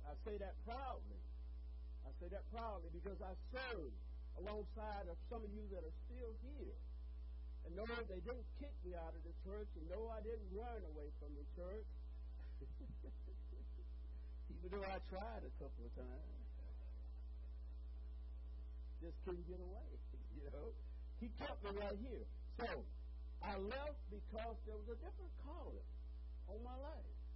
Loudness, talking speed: -52 LUFS, 155 wpm